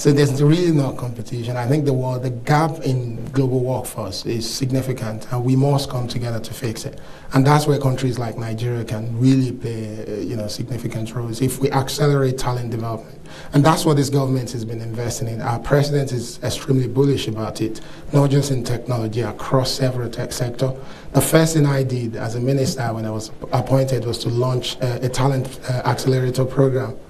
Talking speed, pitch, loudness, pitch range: 195 wpm, 130 Hz, -20 LUFS, 115-135 Hz